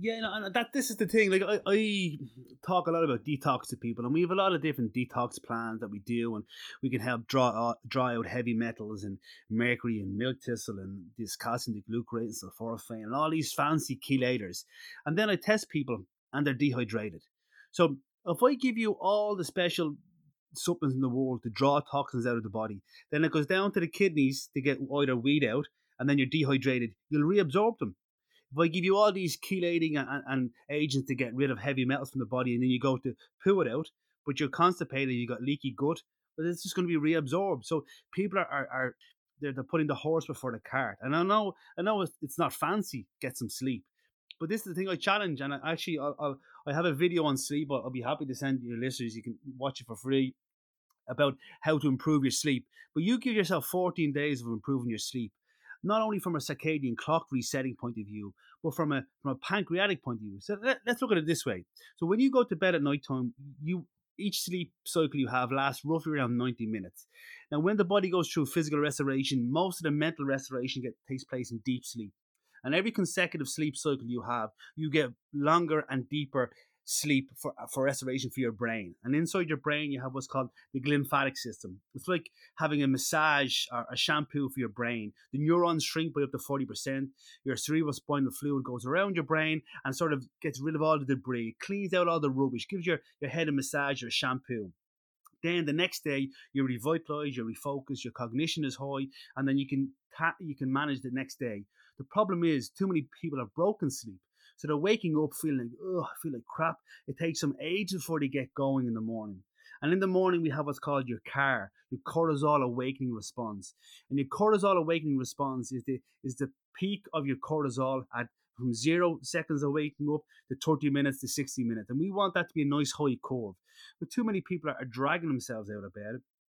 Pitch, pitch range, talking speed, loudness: 140 Hz, 125-165 Hz, 225 wpm, -31 LUFS